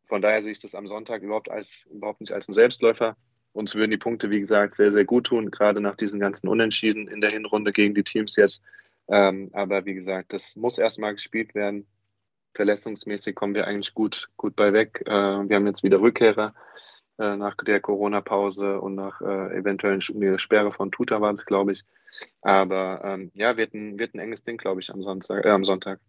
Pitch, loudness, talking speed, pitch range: 105 Hz, -24 LUFS, 200 wpm, 100-110 Hz